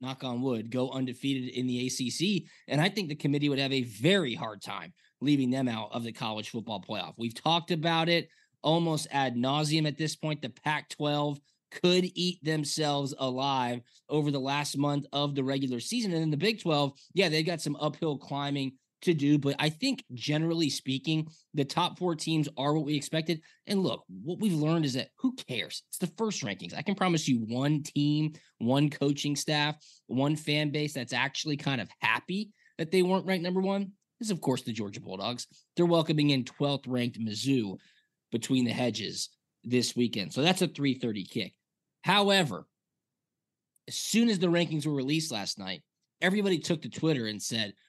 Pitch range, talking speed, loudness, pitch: 130-165 Hz, 190 wpm, -30 LUFS, 150 Hz